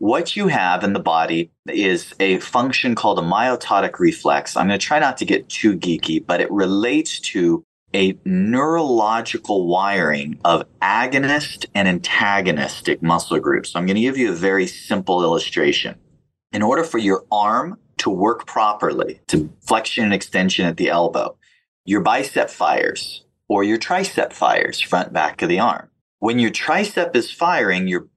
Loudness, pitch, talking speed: -19 LUFS, 105 Hz, 170 wpm